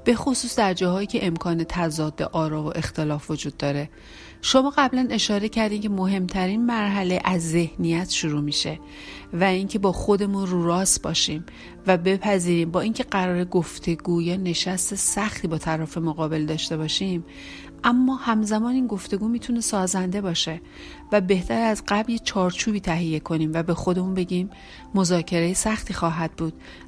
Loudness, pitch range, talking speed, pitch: -23 LUFS, 165-210 Hz, 150 wpm, 185 Hz